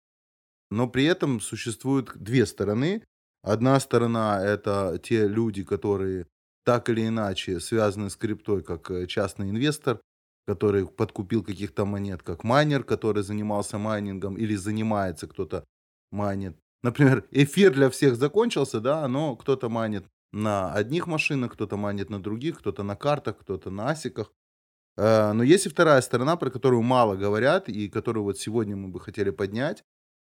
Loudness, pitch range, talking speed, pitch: -25 LUFS, 100-125 Hz, 145 wpm, 105 Hz